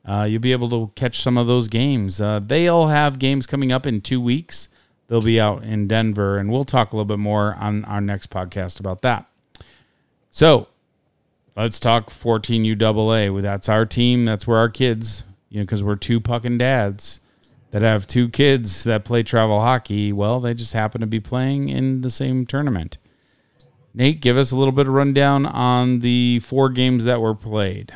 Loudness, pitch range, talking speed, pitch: -19 LUFS, 105-130 Hz, 195 wpm, 115 Hz